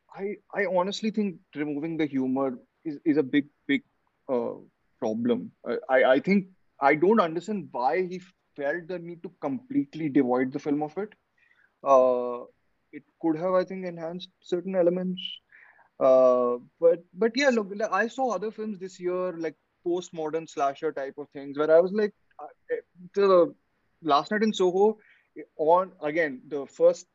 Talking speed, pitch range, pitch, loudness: 160 wpm, 145-200 Hz, 175 Hz, -26 LUFS